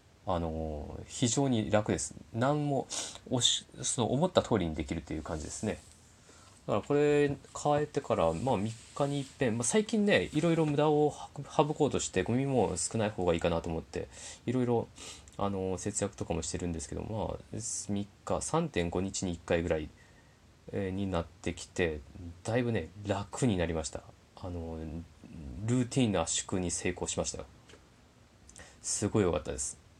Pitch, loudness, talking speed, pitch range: 100 Hz, -32 LUFS, 310 characters per minute, 85-125 Hz